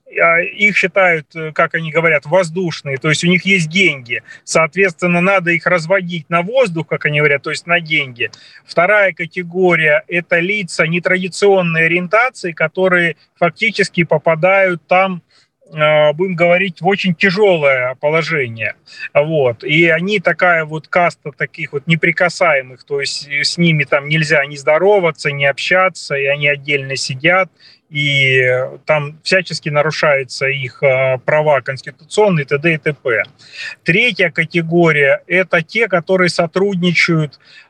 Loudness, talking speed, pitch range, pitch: -14 LUFS, 125 wpm, 150-185 Hz, 170 Hz